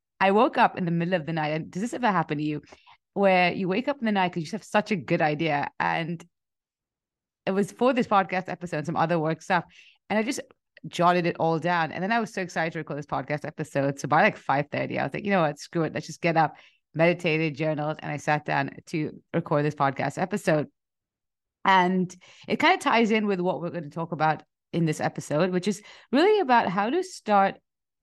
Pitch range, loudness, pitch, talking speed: 155-195 Hz, -25 LUFS, 170 Hz, 235 wpm